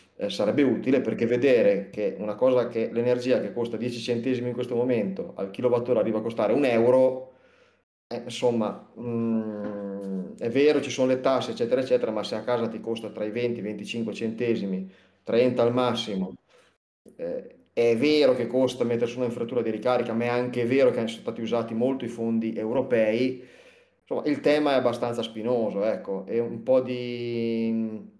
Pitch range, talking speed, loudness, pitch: 115-125 Hz, 175 wpm, -26 LUFS, 120 Hz